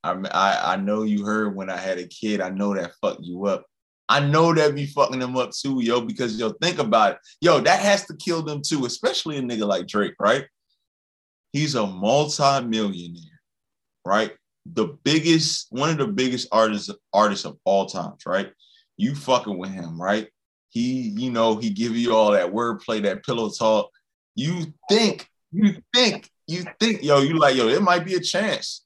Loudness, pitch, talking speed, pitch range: -22 LUFS, 130 Hz, 190 wpm, 105-165 Hz